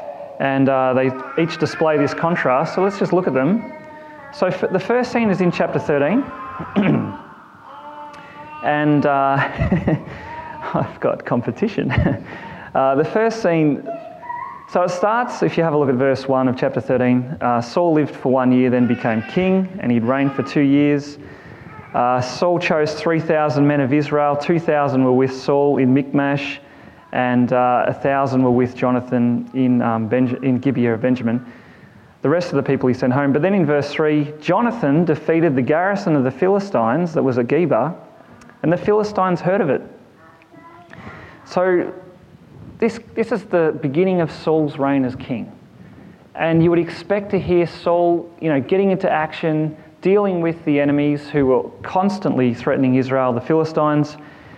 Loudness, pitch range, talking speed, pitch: -18 LUFS, 130-180 Hz, 165 wpm, 150 Hz